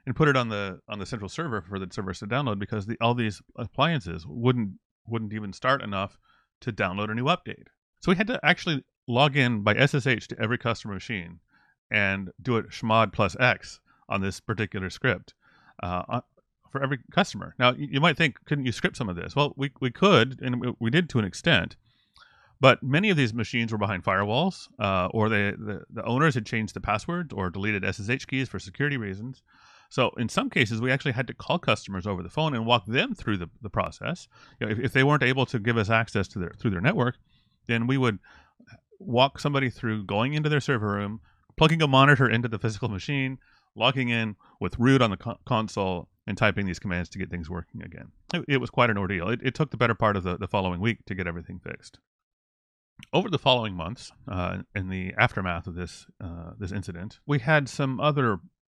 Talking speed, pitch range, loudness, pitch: 215 wpm, 100-130 Hz, -26 LUFS, 115 Hz